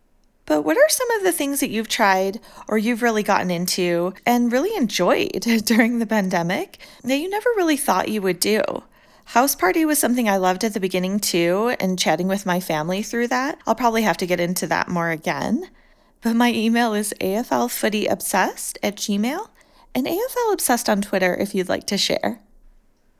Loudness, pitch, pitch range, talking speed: -20 LUFS, 220 Hz, 185-250 Hz, 185 wpm